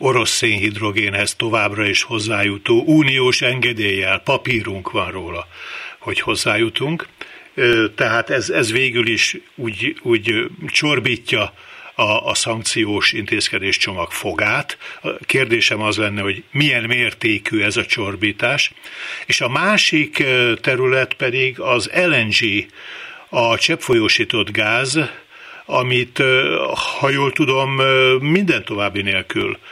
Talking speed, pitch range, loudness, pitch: 105 wpm, 110-155 Hz, -16 LUFS, 125 Hz